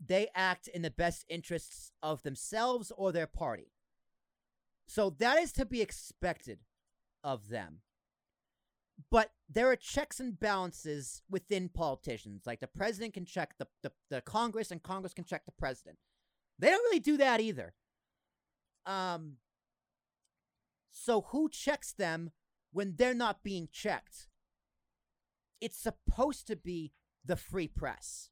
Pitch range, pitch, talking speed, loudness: 150-225 Hz, 185 Hz, 140 wpm, -35 LUFS